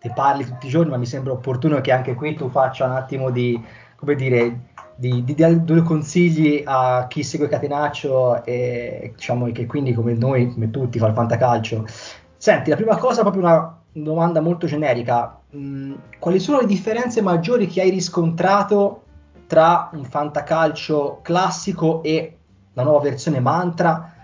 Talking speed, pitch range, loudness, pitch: 160 wpm, 125-165 Hz, -19 LUFS, 145 Hz